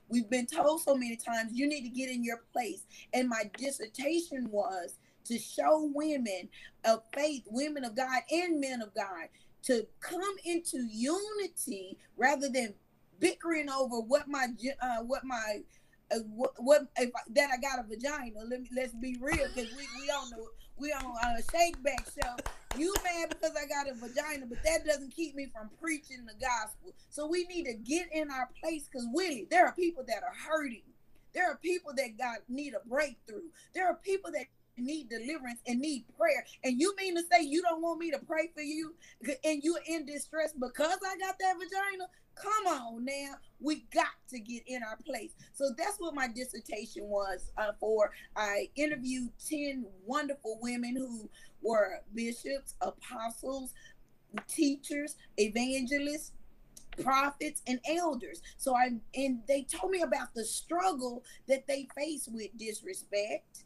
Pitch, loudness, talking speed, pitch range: 275 Hz, -34 LUFS, 175 wpm, 245-315 Hz